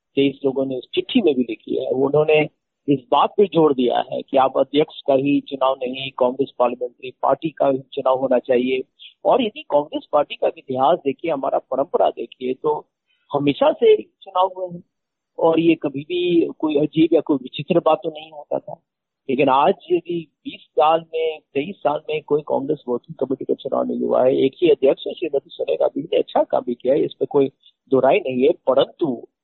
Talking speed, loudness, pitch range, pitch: 200 wpm, -20 LUFS, 135-205 Hz, 155 Hz